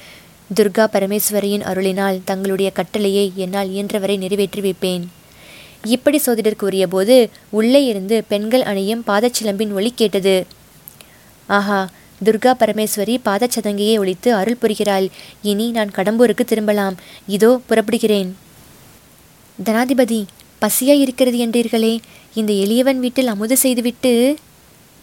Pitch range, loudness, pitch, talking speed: 195-235 Hz, -17 LUFS, 215 Hz, 100 wpm